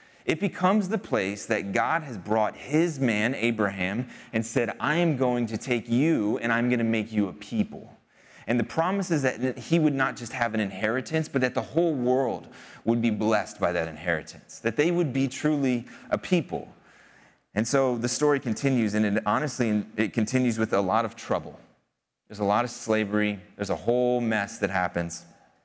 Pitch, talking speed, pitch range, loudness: 120 Hz, 190 wpm, 105-135 Hz, -26 LUFS